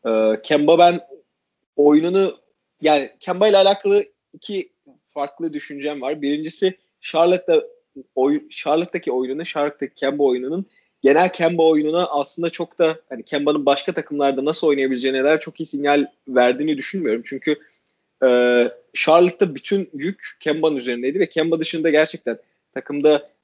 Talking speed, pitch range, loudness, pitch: 130 wpm, 145-180 Hz, -19 LUFS, 155 Hz